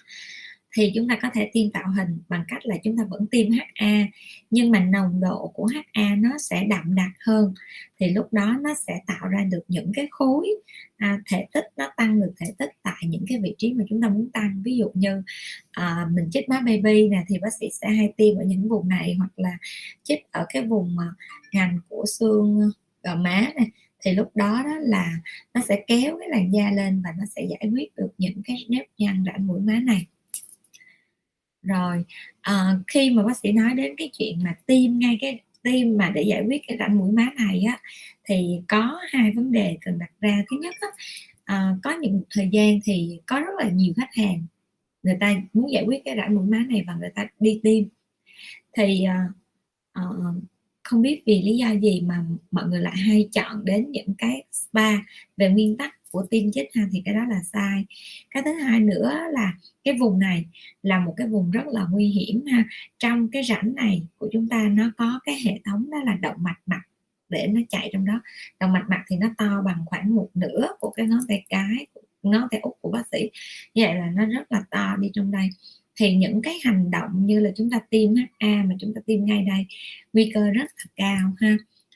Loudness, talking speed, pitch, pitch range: -23 LUFS, 220 wpm, 210 Hz, 190-230 Hz